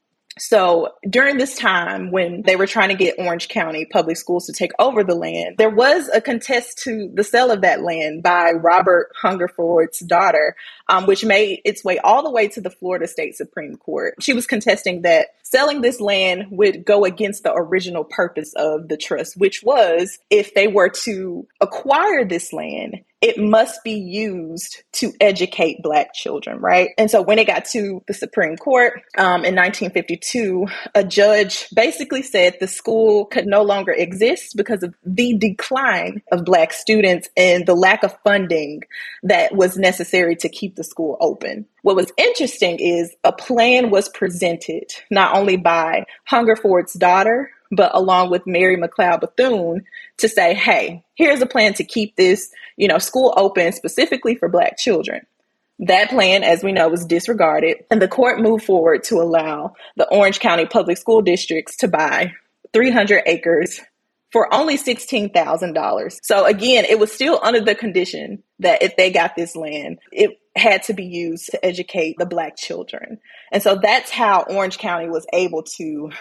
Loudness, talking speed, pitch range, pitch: -17 LUFS, 170 wpm, 175-230 Hz, 200 Hz